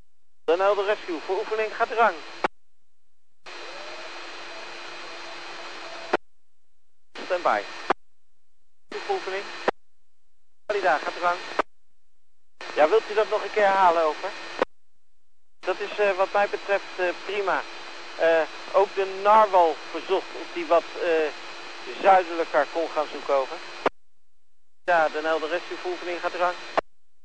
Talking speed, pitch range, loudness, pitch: 120 wpm, 165-210 Hz, -25 LUFS, 190 Hz